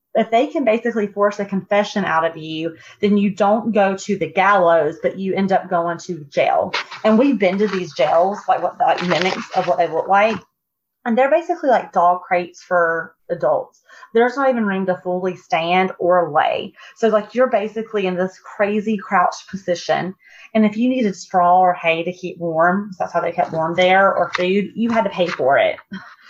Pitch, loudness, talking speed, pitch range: 190 Hz, -18 LUFS, 205 wpm, 175-215 Hz